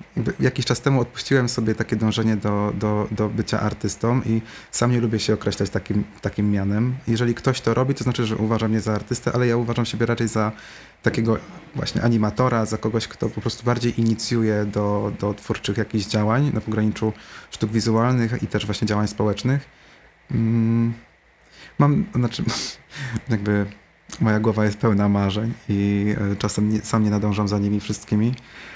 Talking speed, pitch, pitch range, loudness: 170 wpm, 110 Hz, 105-115 Hz, -22 LUFS